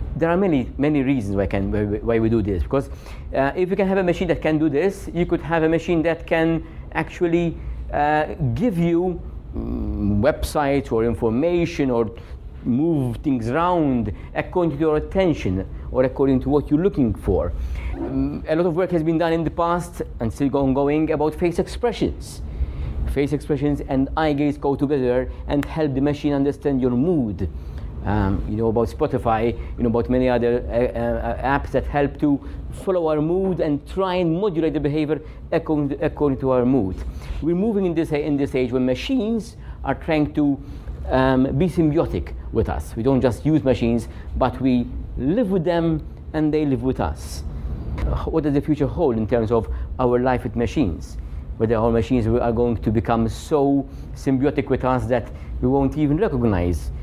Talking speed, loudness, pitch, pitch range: 185 wpm, -21 LUFS, 135 Hz, 115-155 Hz